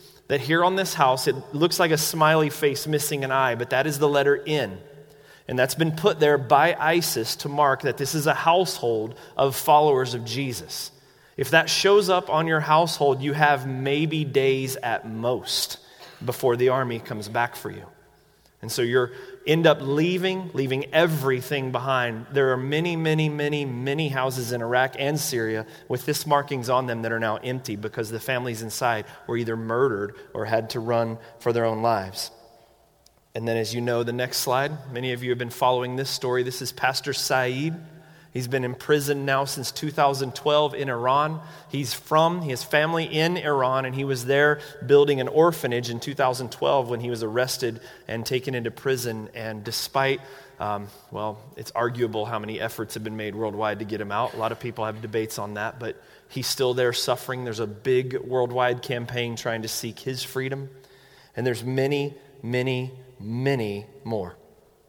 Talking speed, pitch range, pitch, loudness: 185 wpm, 120-145 Hz, 130 Hz, -24 LUFS